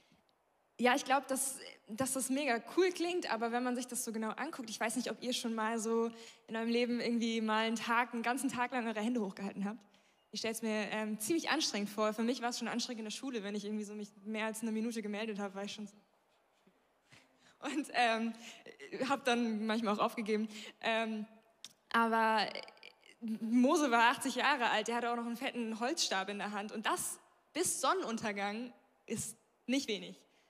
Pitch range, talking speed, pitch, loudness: 215-250 Hz, 205 wpm, 230 Hz, -35 LUFS